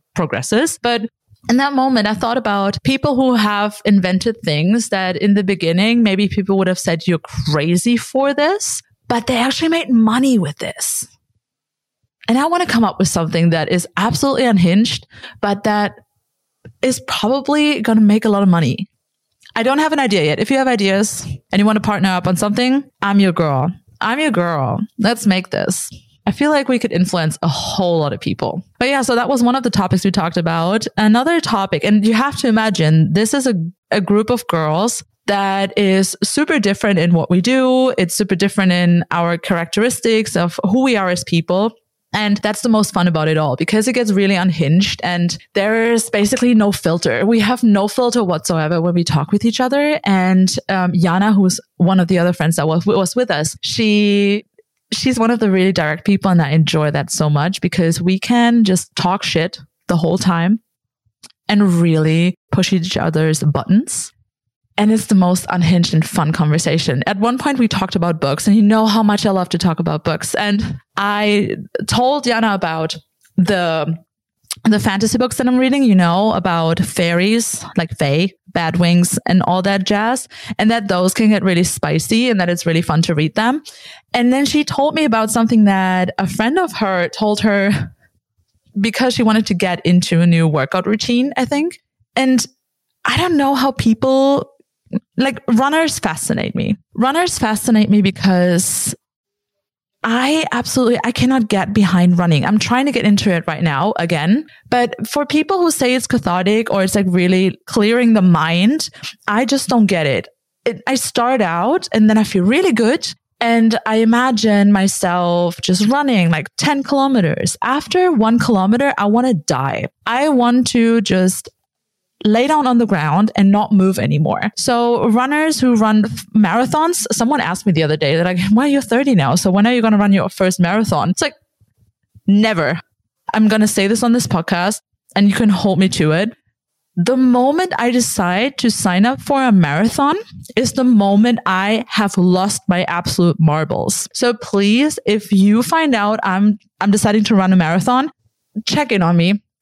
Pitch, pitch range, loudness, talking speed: 205 Hz, 175-235 Hz, -15 LUFS, 190 wpm